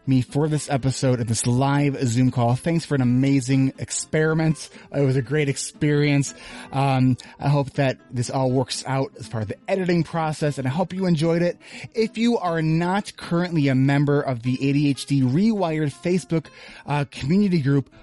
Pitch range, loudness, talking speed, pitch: 130-165 Hz, -22 LUFS, 180 wpm, 140 Hz